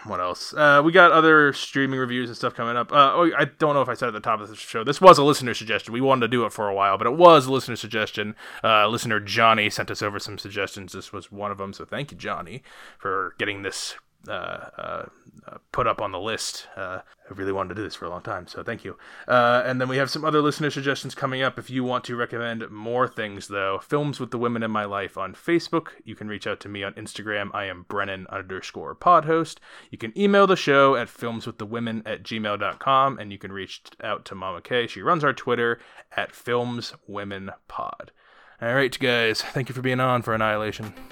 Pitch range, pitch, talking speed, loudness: 105-135 Hz, 115 Hz, 245 wpm, -22 LUFS